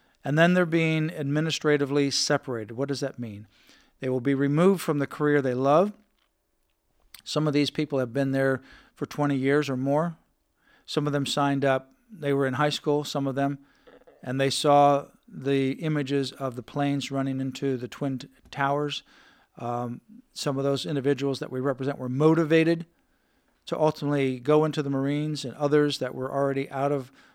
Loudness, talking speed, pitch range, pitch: -26 LUFS, 175 wpm, 135-150 Hz, 140 Hz